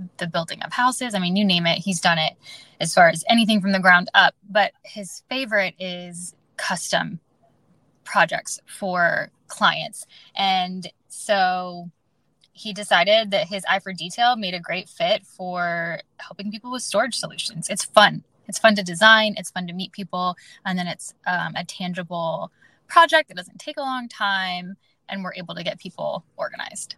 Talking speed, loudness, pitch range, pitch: 175 wpm, -21 LUFS, 180-215 Hz, 190 Hz